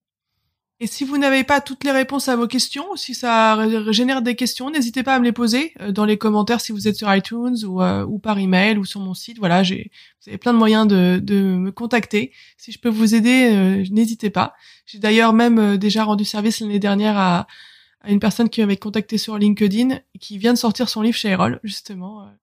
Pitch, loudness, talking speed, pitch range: 220 Hz, -18 LUFS, 230 wpm, 205-245 Hz